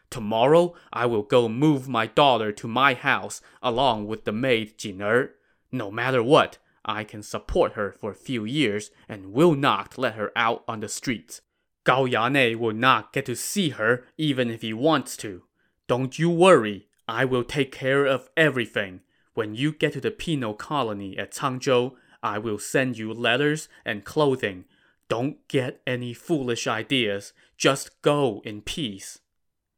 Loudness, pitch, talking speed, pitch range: -24 LUFS, 120 Hz, 165 wpm, 110-140 Hz